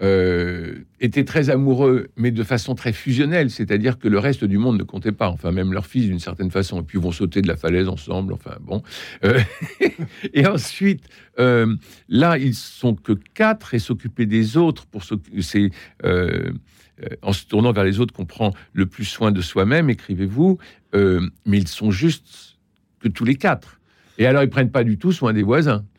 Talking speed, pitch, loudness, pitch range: 200 wpm, 110 Hz, -20 LUFS, 95-130 Hz